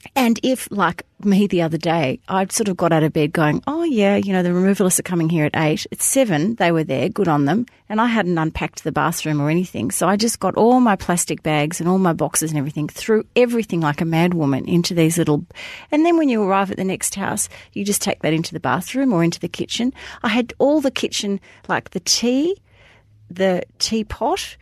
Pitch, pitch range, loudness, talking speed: 185 Hz, 160-225 Hz, -19 LUFS, 230 wpm